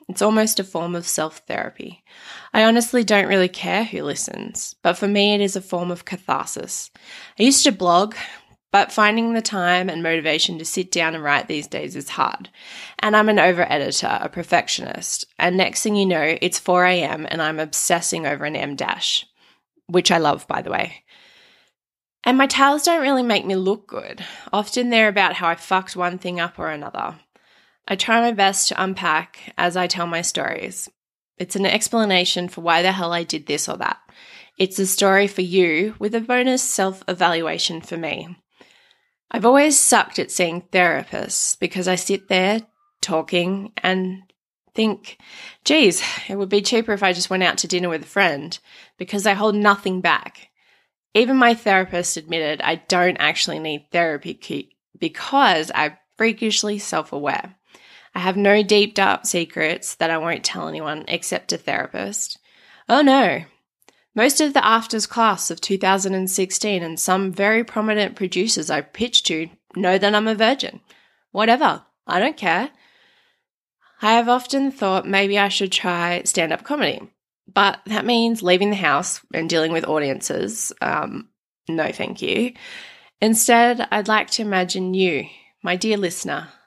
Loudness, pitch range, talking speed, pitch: -19 LUFS, 175-220 Hz, 170 wpm, 195 Hz